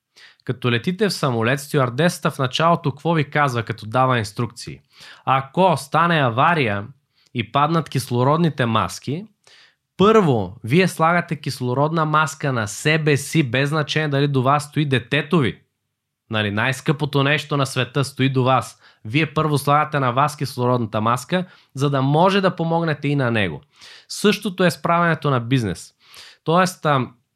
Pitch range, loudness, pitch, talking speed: 125-160 Hz, -19 LUFS, 140 Hz, 145 wpm